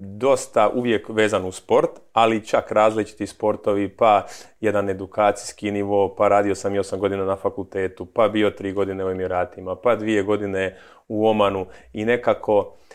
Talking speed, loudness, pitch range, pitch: 160 wpm, -21 LUFS, 95-110 Hz, 100 Hz